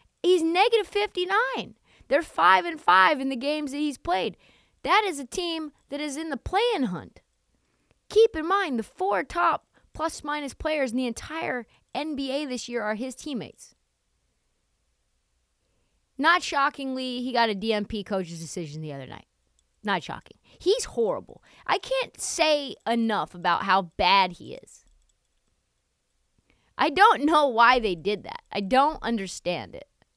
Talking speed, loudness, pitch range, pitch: 150 wpm, -25 LUFS, 220-335 Hz, 280 Hz